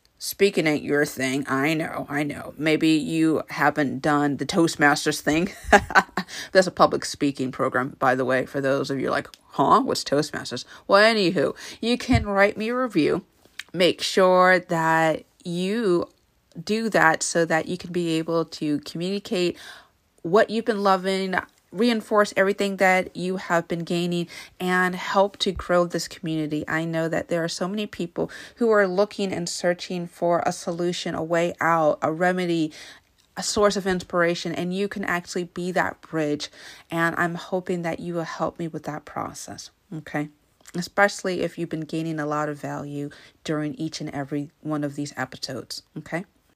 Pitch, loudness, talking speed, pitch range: 170 Hz, -23 LUFS, 170 wpm, 150-185 Hz